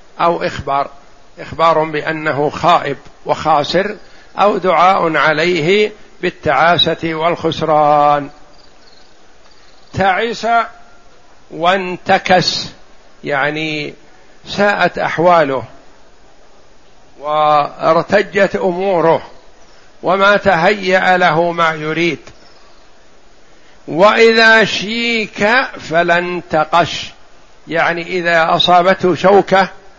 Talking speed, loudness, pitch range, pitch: 60 wpm, -13 LUFS, 160-195 Hz, 175 Hz